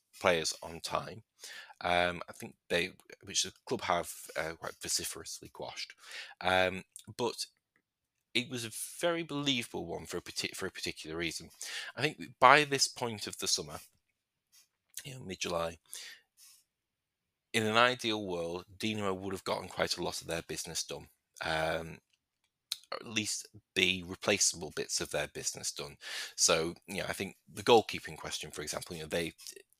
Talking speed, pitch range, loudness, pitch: 160 wpm, 90-120 Hz, -33 LUFS, 105 Hz